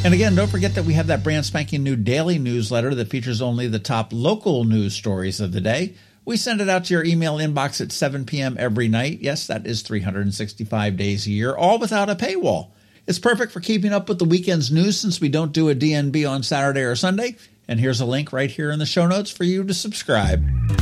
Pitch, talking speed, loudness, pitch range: 140 Hz, 235 wpm, -21 LUFS, 110-180 Hz